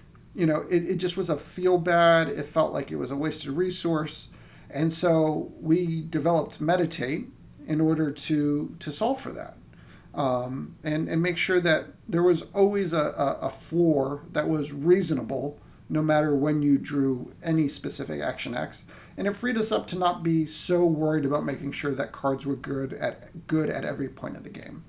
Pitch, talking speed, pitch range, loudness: 155 Hz, 190 wpm, 145-170 Hz, -26 LUFS